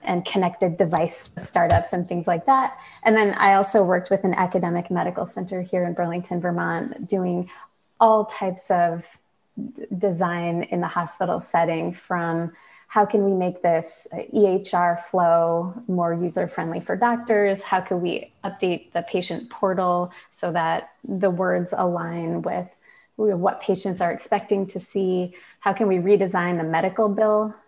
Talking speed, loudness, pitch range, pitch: 150 wpm, -23 LUFS, 175-200 Hz, 185 Hz